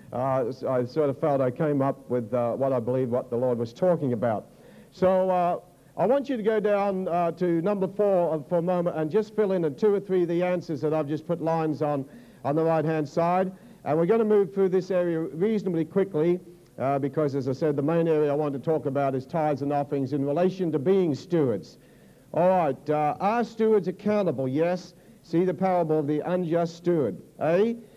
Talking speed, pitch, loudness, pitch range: 220 wpm, 165 Hz, -26 LUFS, 145-185 Hz